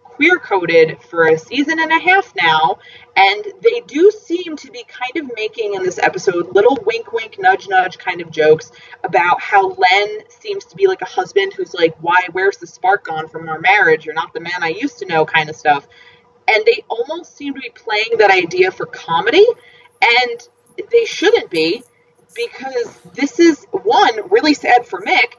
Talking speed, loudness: 195 wpm, -15 LUFS